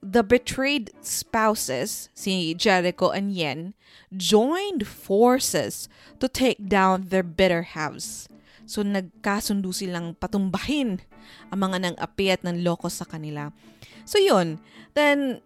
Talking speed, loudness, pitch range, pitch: 115 wpm, -24 LUFS, 175-215 Hz, 190 Hz